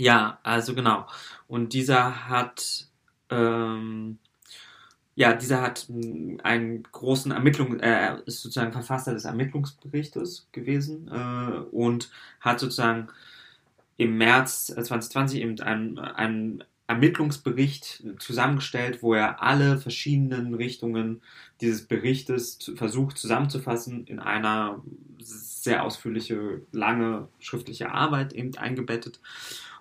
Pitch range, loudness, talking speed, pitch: 115-130 Hz, -26 LUFS, 105 wpm, 120 Hz